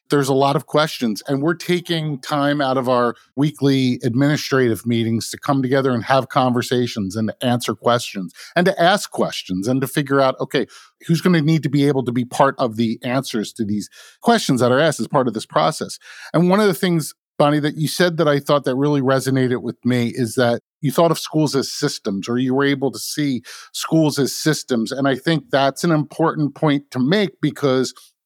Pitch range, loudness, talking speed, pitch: 125-150 Hz, -19 LUFS, 215 wpm, 135 Hz